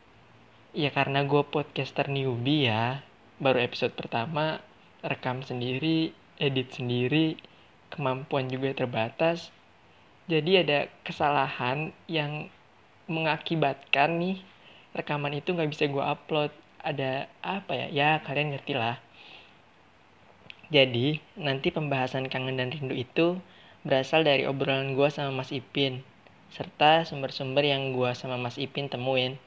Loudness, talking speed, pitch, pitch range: -28 LUFS, 115 wpm, 140 Hz, 130-155 Hz